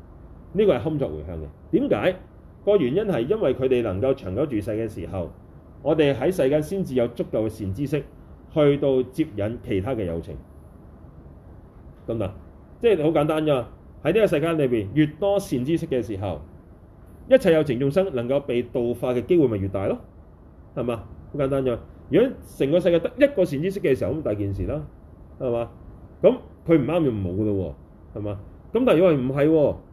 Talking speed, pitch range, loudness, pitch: 275 characters per minute, 85-140 Hz, -23 LUFS, 110 Hz